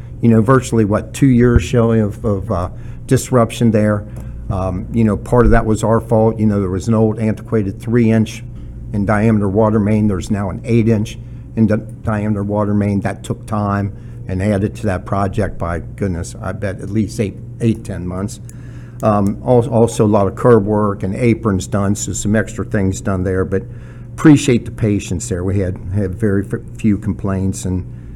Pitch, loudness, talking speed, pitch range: 110 Hz, -16 LUFS, 190 wpm, 100-115 Hz